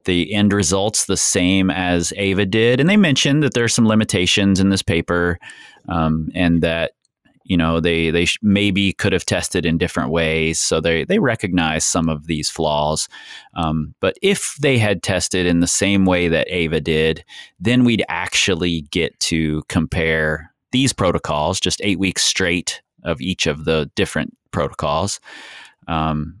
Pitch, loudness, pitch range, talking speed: 90 Hz, -18 LUFS, 80-100 Hz, 170 wpm